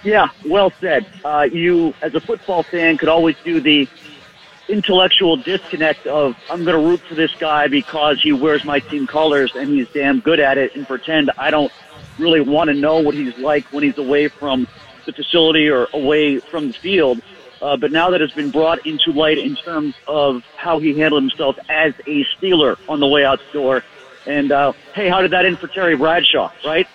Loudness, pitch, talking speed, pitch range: -16 LUFS, 155 Hz, 205 wpm, 145-170 Hz